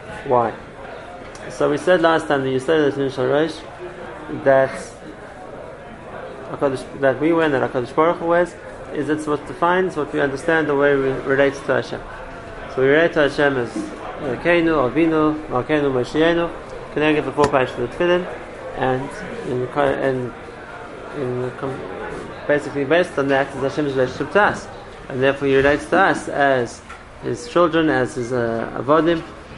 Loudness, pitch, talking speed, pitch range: -19 LUFS, 145 Hz, 150 wpm, 135-160 Hz